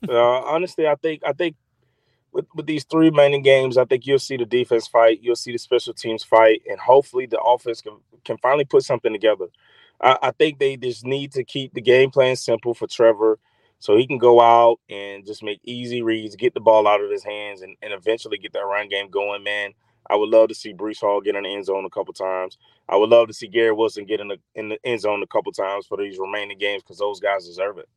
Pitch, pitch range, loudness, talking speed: 120 Hz, 110-155 Hz, -20 LUFS, 250 wpm